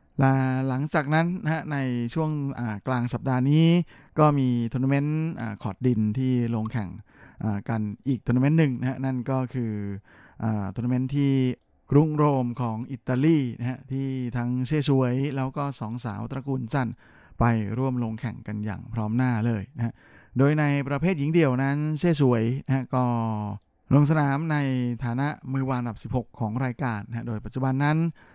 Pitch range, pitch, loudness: 115-140 Hz, 130 Hz, -26 LUFS